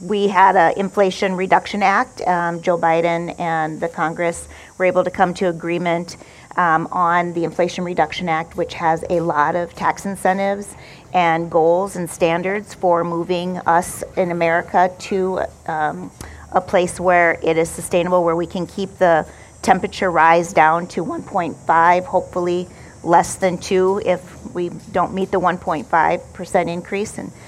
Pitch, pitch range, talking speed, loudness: 175 Hz, 170-185 Hz, 155 wpm, -18 LUFS